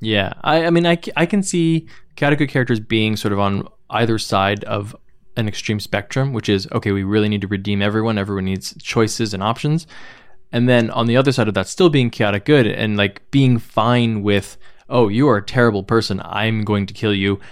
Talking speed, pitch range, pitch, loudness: 215 wpm, 100-125 Hz, 110 Hz, -18 LUFS